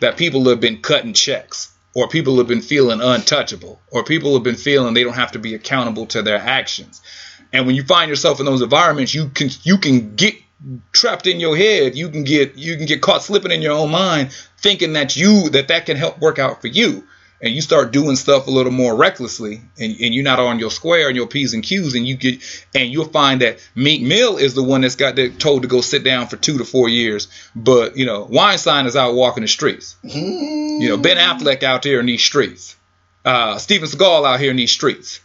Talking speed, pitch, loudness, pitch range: 235 wpm, 135 Hz, -15 LUFS, 120-155 Hz